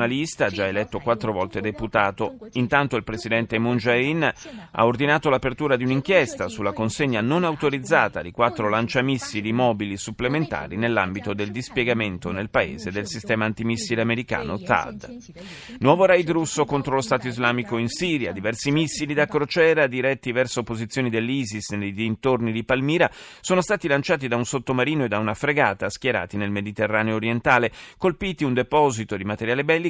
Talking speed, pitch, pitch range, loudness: 155 wpm, 120 Hz, 110-145 Hz, -23 LUFS